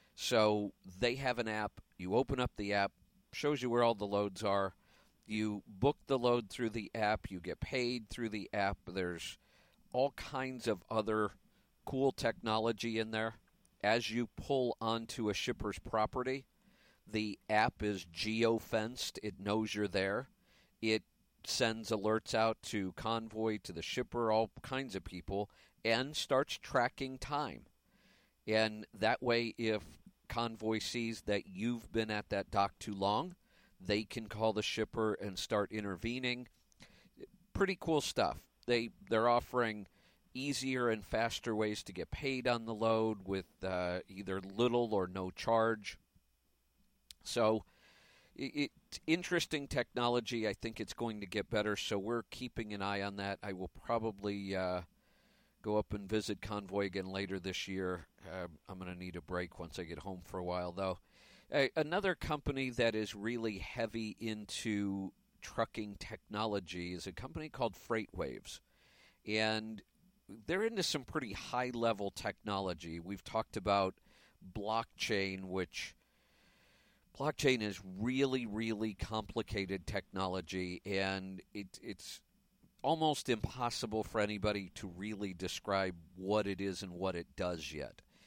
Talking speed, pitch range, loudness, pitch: 145 wpm, 95-120 Hz, -37 LUFS, 110 Hz